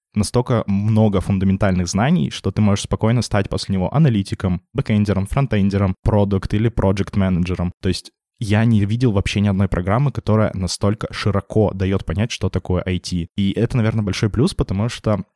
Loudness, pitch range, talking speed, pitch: -19 LUFS, 95-110 Hz, 160 wpm, 100 Hz